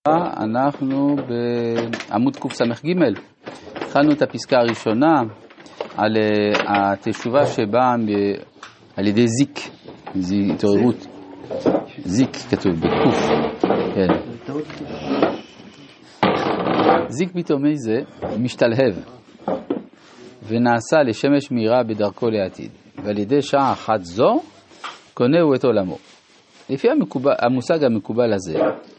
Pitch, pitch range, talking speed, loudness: 120 Hz, 105-135 Hz, 85 wpm, -19 LUFS